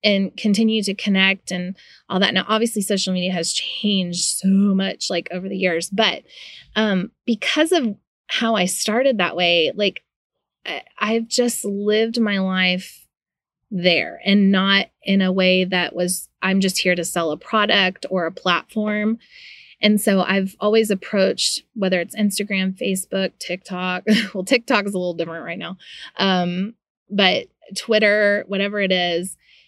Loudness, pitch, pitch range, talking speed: -19 LUFS, 195 Hz, 185-210 Hz, 155 wpm